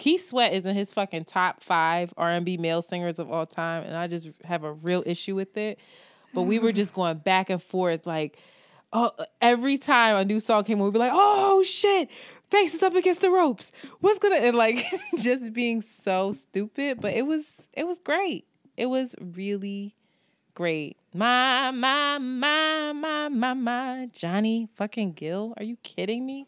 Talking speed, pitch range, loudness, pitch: 190 wpm, 185-265 Hz, -25 LUFS, 220 Hz